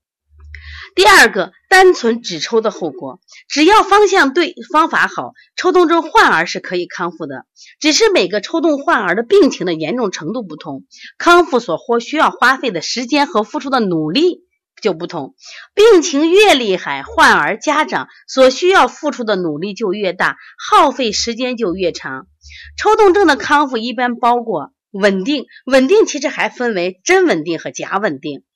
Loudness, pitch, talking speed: -13 LUFS, 255 Hz, 250 characters per minute